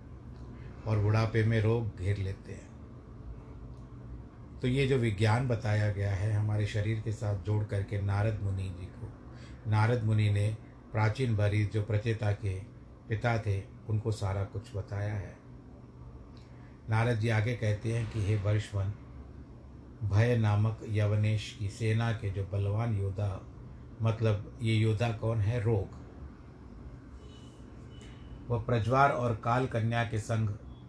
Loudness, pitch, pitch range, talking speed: -31 LUFS, 110 Hz, 100-115 Hz, 135 wpm